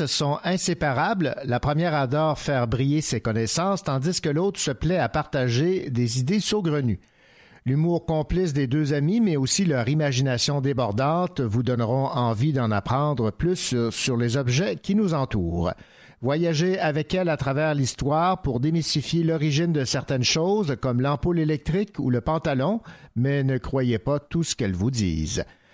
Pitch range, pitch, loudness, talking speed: 130-165 Hz, 145 Hz, -24 LUFS, 160 wpm